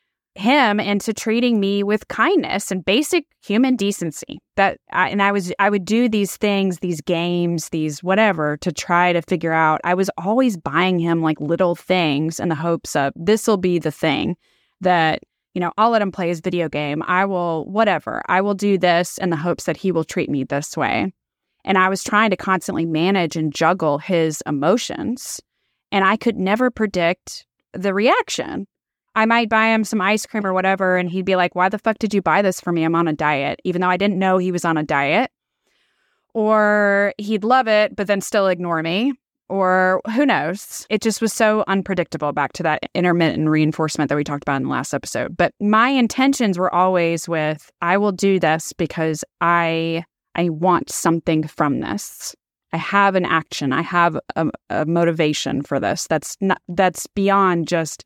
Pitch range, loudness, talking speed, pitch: 165-205 Hz, -19 LUFS, 195 wpm, 185 Hz